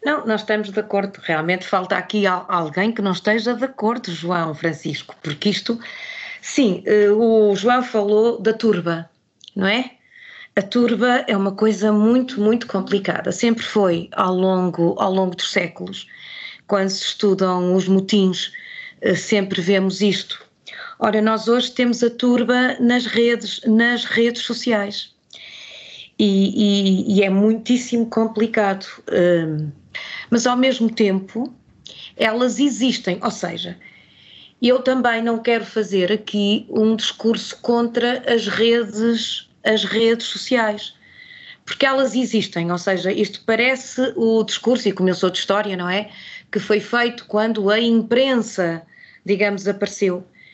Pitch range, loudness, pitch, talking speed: 195-235 Hz, -19 LUFS, 215 Hz, 135 wpm